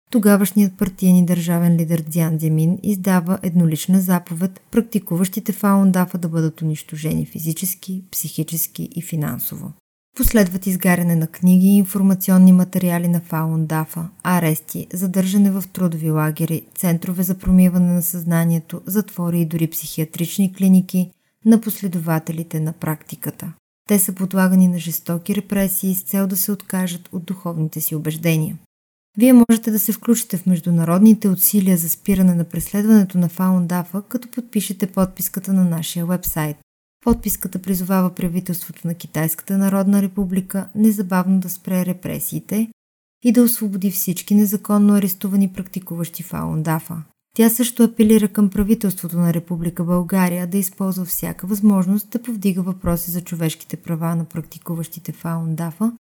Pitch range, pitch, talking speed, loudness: 170-200 Hz, 185 Hz, 130 wpm, -18 LUFS